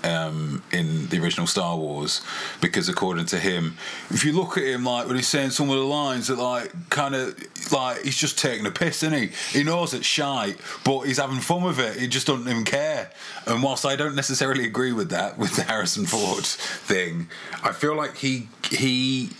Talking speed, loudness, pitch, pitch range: 210 wpm, -24 LUFS, 135 Hz, 120-150 Hz